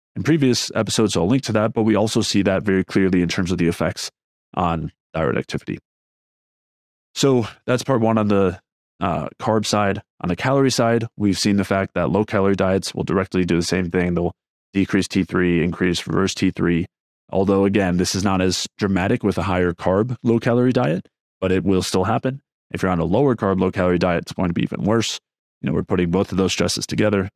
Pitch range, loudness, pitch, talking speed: 90-110 Hz, -20 LUFS, 95 Hz, 215 wpm